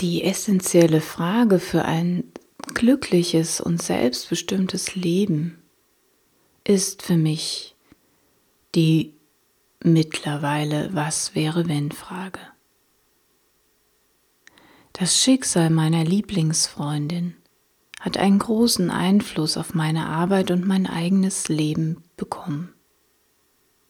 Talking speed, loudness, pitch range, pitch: 85 wpm, -21 LUFS, 160-195 Hz, 170 Hz